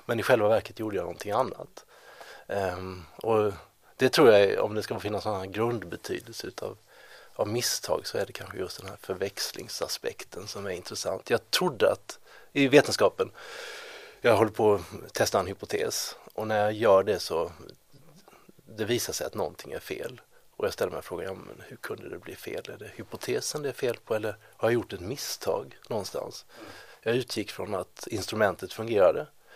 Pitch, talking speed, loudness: 140 Hz, 175 wpm, -28 LUFS